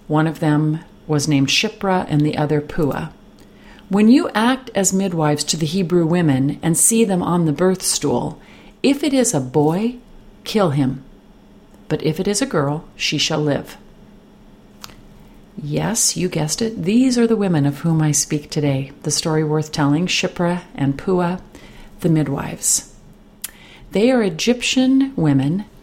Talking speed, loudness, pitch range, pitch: 160 wpm, -18 LUFS, 150-205 Hz, 165 Hz